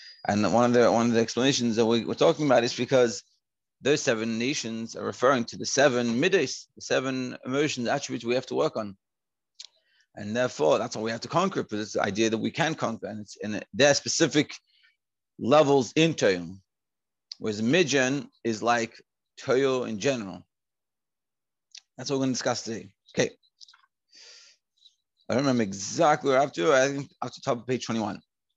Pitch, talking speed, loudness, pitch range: 120 Hz, 195 wpm, -26 LUFS, 115-135 Hz